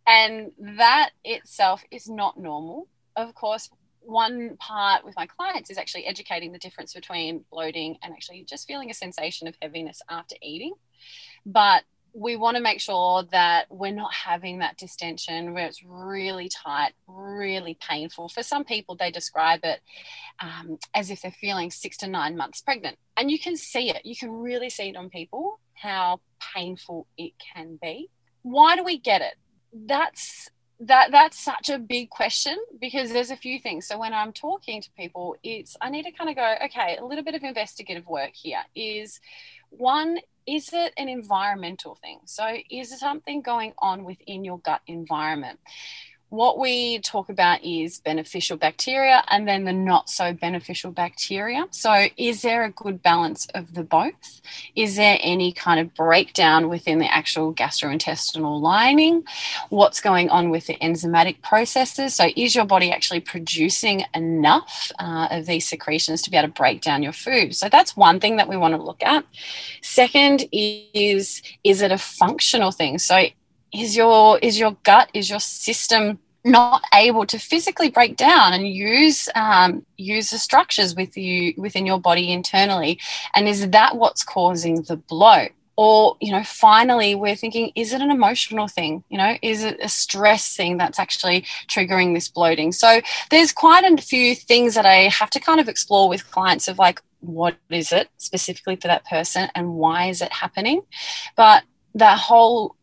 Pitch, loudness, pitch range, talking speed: 200 Hz, -18 LUFS, 170-235 Hz, 175 wpm